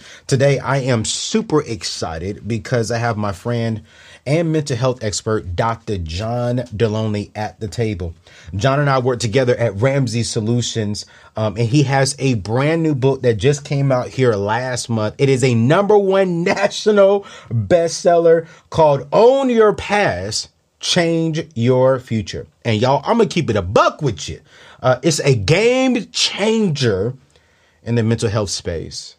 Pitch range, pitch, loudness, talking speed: 115-155 Hz, 130 Hz, -17 LUFS, 160 wpm